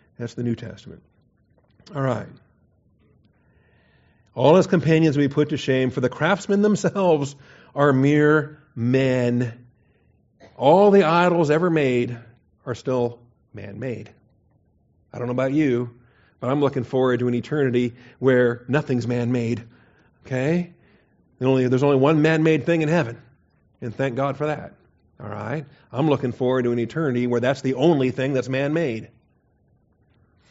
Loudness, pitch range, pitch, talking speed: -21 LUFS, 120-150 Hz, 130 Hz, 150 wpm